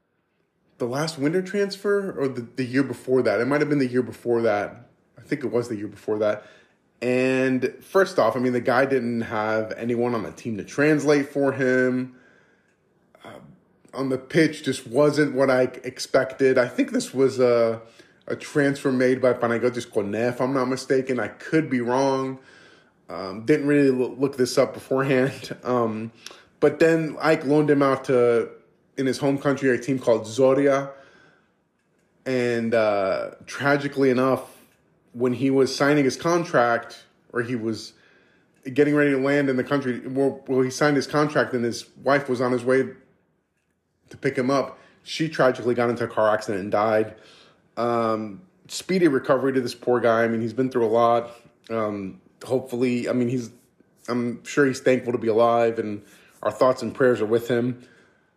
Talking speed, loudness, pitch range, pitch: 180 wpm, -23 LUFS, 120-140 Hz, 130 Hz